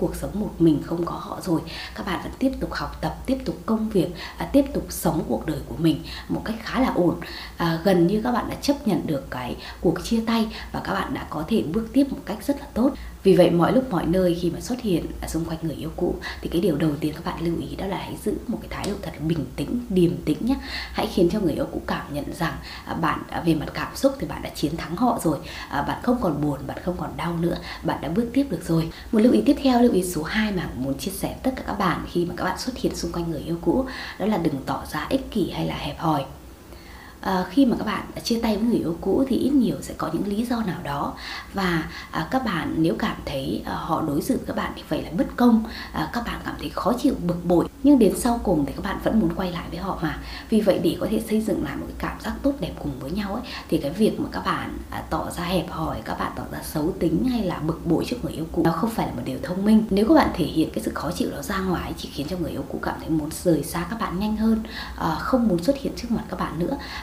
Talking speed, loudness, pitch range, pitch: 290 wpm, -24 LUFS, 165-230 Hz, 185 Hz